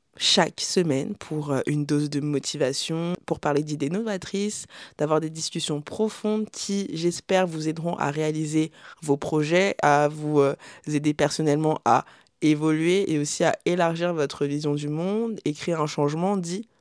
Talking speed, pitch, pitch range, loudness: 150 wpm, 155 Hz, 150-180 Hz, -25 LUFS